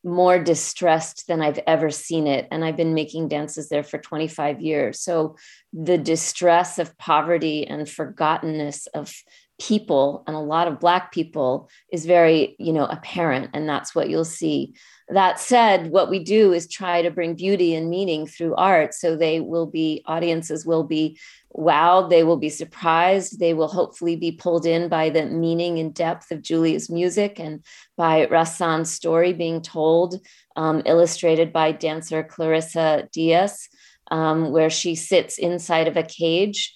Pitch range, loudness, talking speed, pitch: 155-175 Hz, -21 LUFS, 165 wpm, 165 Hz